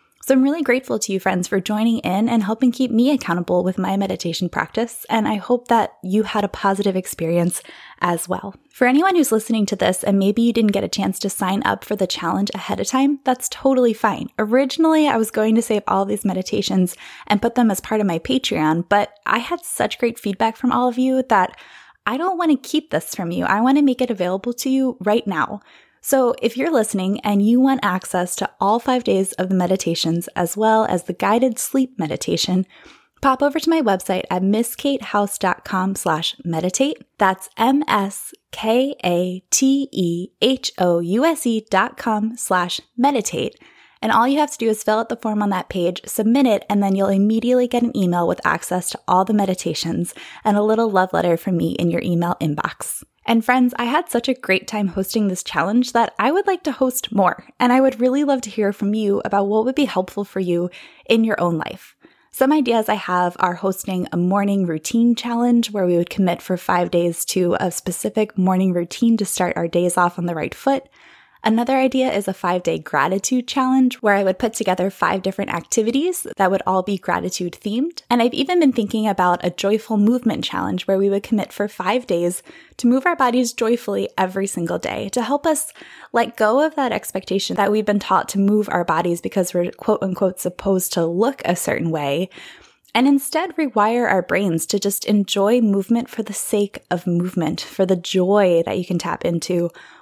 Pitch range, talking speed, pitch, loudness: 185-245 Hz, 205 wpm, 210 Hz, -19 LUFS